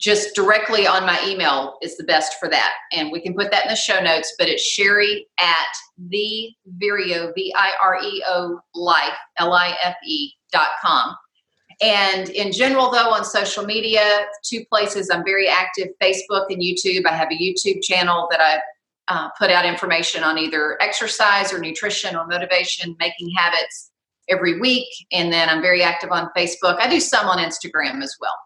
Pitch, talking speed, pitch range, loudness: 185 Hz, 185 wpm, 170-210 Hz, -18 LUFS